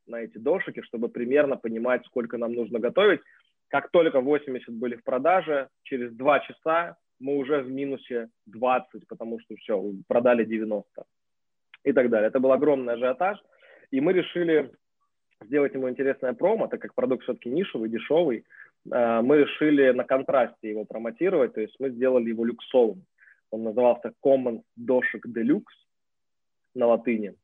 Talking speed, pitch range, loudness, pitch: 150 wpm, 115-140 Hz, -25 LUFS, 125 Hz